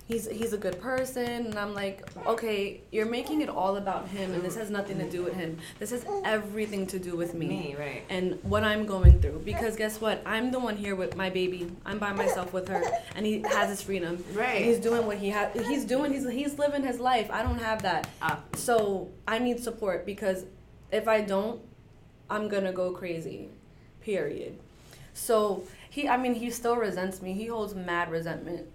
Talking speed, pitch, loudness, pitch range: 205 wpm, 205 Hz, -30 LUFS, 185-230 Hz